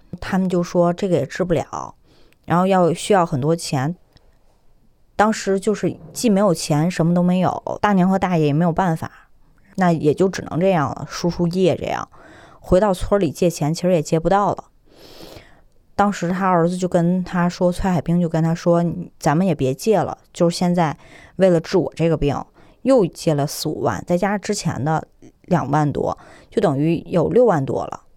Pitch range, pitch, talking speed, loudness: 160-185 Hz, 175 Hz, 260 characters per minute, -19 LUFS